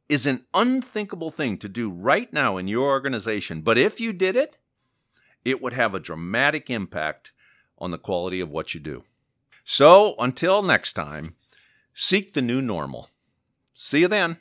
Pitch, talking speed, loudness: 130 Hz, 165 wpm, -22 LUFS